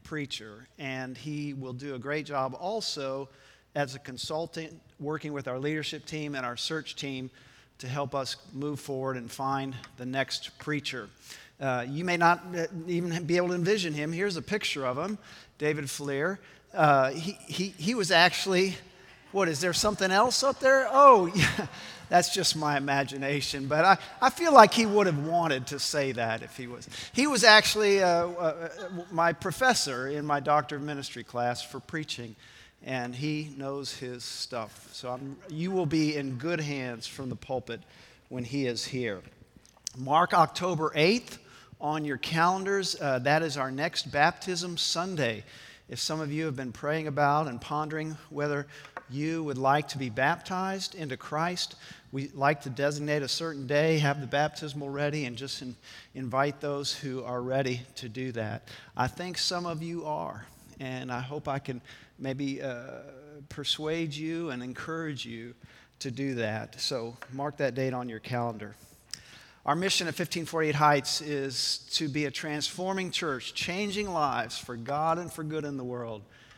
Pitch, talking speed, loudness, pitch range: 145 Hz, 170 wpm, -28 LUFS, 130-165 Hz